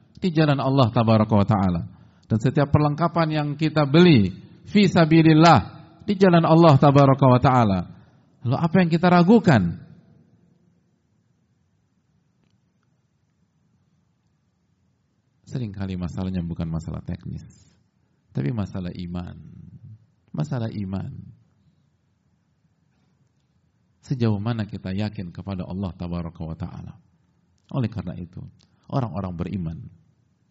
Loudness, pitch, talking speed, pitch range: -20 LUFS, 115 Hz, 90 wpm, 95-150 Hz